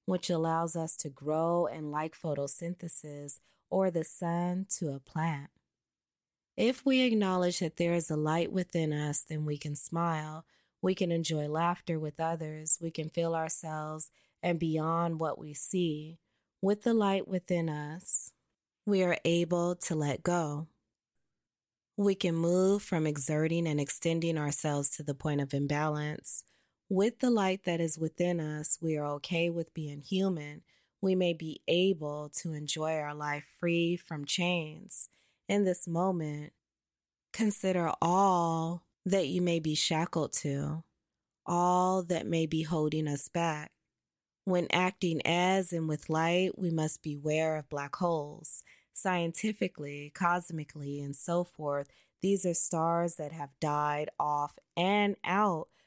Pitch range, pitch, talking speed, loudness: 150-175 Hz, 165 Hz, 145 wpm, -28 LUFS